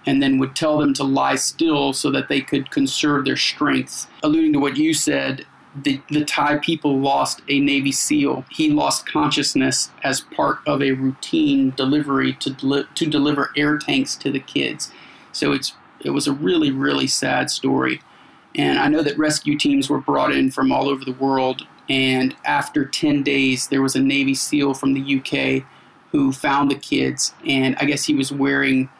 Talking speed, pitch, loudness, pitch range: 190 wpm, 140 Hz, -19 LUFS, 135-150 Hz